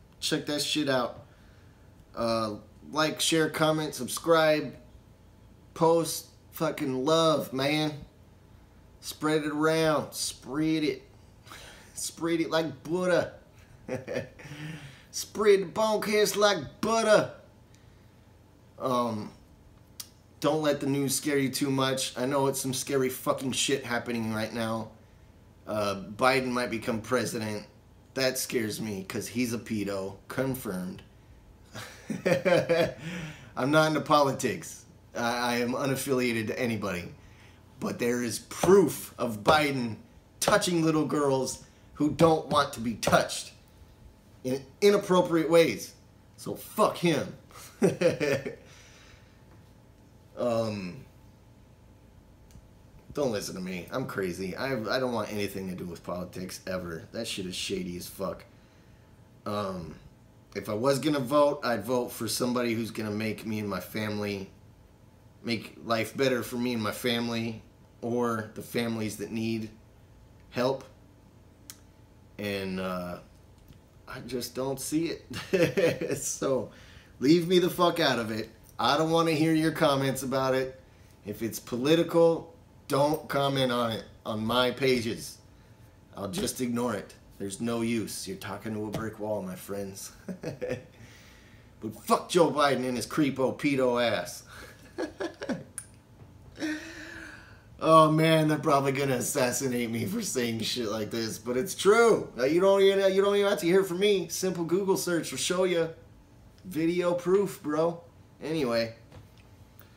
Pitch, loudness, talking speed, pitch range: 120 Hz, -28 LUFS, 130 wpm, 105-150 Hz